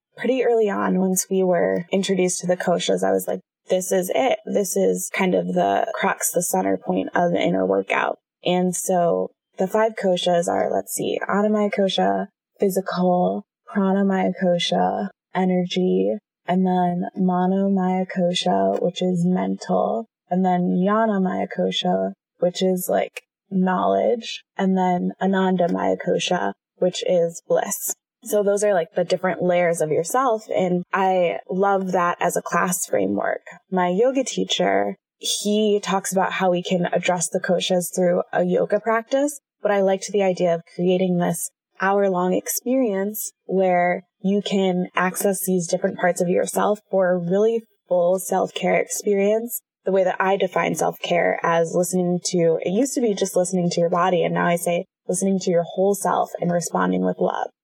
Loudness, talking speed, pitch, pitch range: -21 LUFS, 165 wpm, 185 Hz, 175-195 Hz